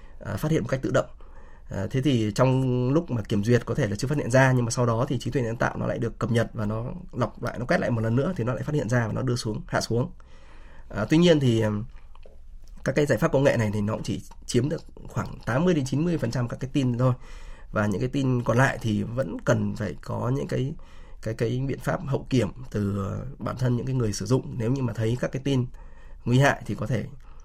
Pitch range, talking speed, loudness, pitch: 105-130 Hz, 270 wpm, -26 LUFS, 120 Hz